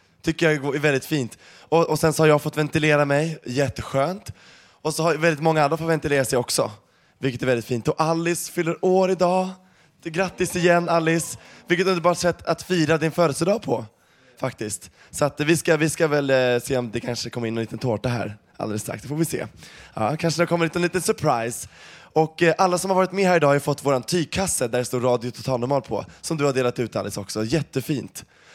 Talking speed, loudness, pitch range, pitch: 220 wpm, -22 LUFS, 125-170 Hz, 150 Hz